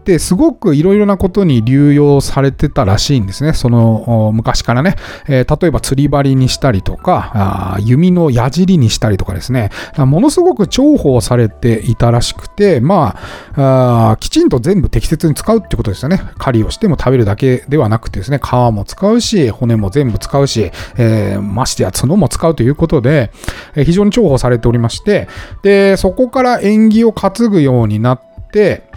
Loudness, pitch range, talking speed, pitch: -12 LUFS, 115-180 Hz, 360 characters per minute, 135 Hz